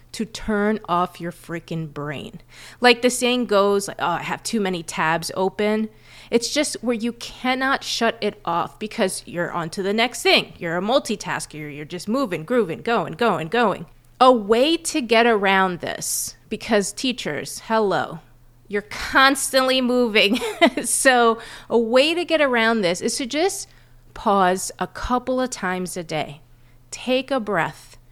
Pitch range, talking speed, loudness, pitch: 170-245 Hz, 155 wpm, -21 LUFS, 210 Hz